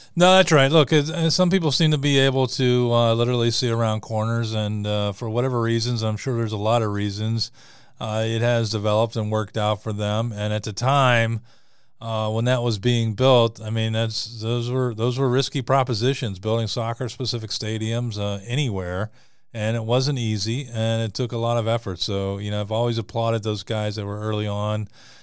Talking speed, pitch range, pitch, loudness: 195 wpm, 110-125 Hz, 115 Hz, -22 LUFS